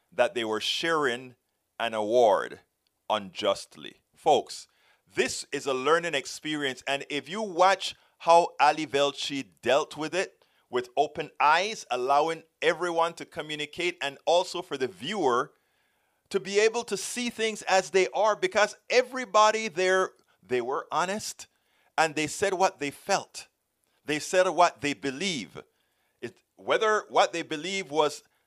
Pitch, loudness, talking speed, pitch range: 175 Hz, -27 LUFS, 140 wpm, 145-200 Hz